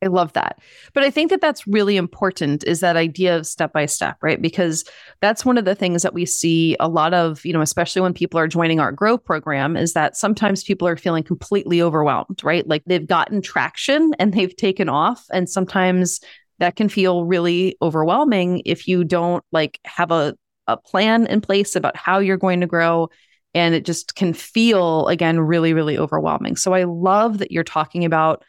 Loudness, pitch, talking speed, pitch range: -19 LUFS, 175 Hz, 200 wpm, 165-195 Hz